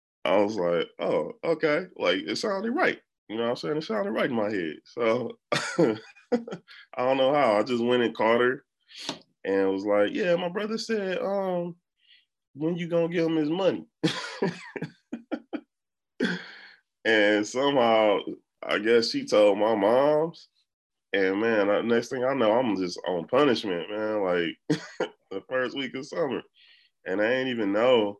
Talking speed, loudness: 160 wpm, -26 LUFS